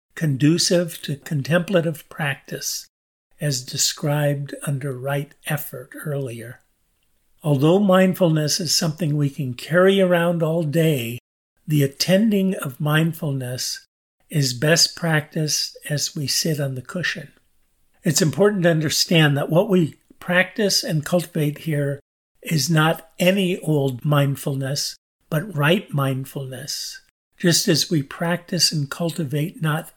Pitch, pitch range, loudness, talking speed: 155 Hz, 140-175 Hz, -21 LUFS, 120 wpm